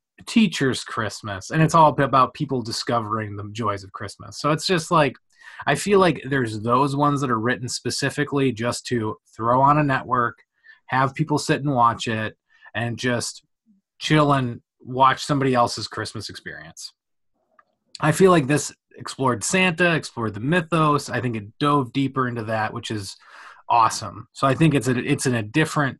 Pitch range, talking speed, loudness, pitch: 115-150 Hz, 175 wpm, -21 LUFS, 130 Hz